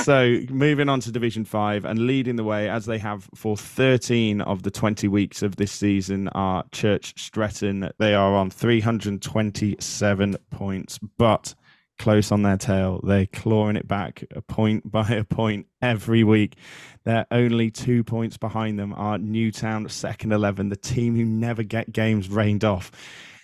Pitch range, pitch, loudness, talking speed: 100-115 Hz, 110 Hz, -23 LUFS, 170 wpm